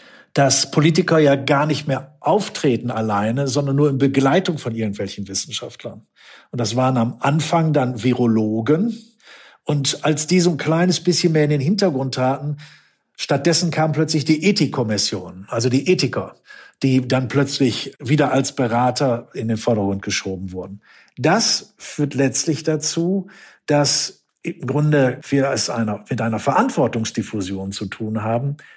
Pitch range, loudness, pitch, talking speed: 115-155 Hz, -19 LUFS, 140 Hz, 140 wpm